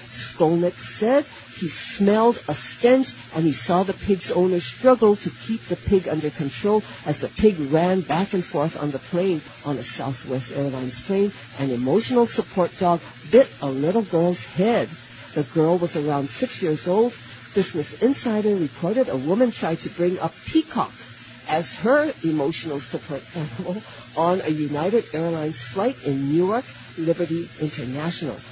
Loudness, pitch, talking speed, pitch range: -23 LUFS, 165 Hz, 155 wpm, 145-195 Hz